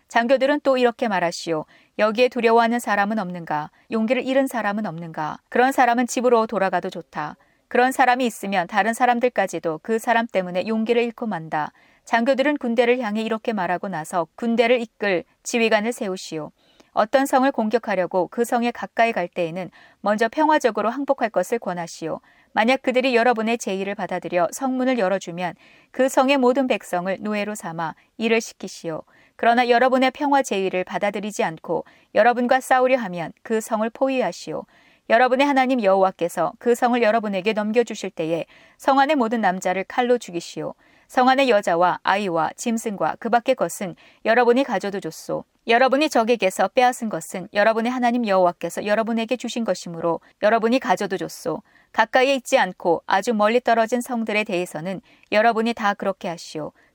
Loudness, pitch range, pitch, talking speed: -21 LUFS, 185-250 Hz, 225 Hz, 385 characters per minute